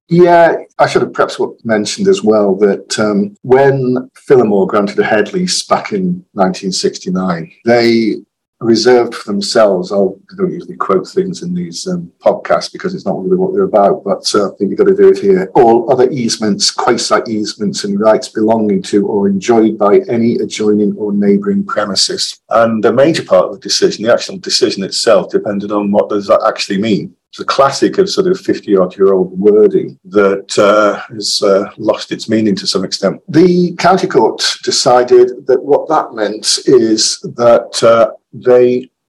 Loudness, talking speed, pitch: -12 LUFS, 180 wpm, 125 Hz